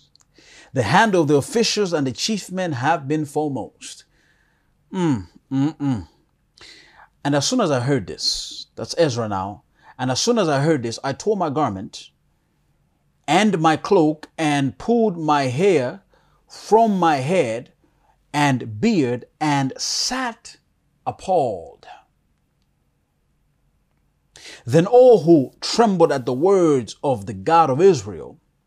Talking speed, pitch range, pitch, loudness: 130 wpm, 125-180 Hz, 150 Hz, -19 LUFS